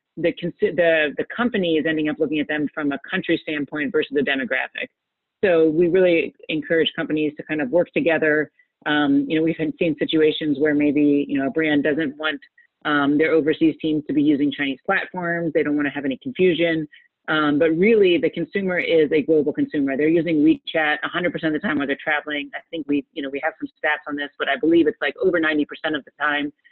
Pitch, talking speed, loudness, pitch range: 155 Hz, 225 wpm, -21 LUFS, 150-170 Hz